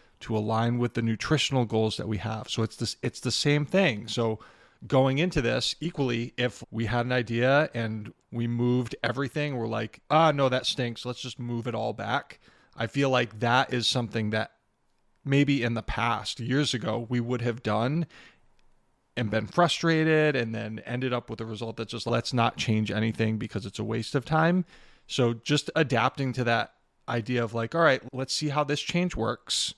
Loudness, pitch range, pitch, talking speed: -27 LUFS, 115-140 Hz, 120 Hz, 200 wpm